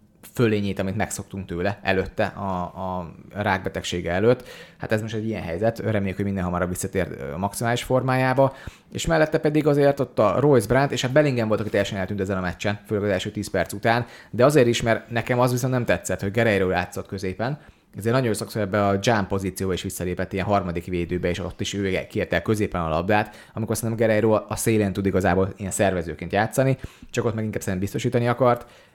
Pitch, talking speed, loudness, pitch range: 105 Hz, 200 wpm, -23 LUFS, 95-115 Hz